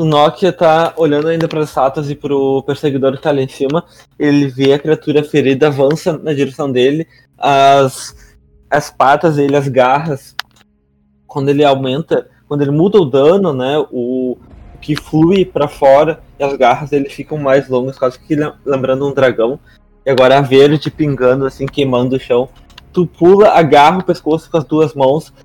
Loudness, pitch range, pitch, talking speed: -13 LUFS, 135-155 Hz, 140 Hz, 175 wpm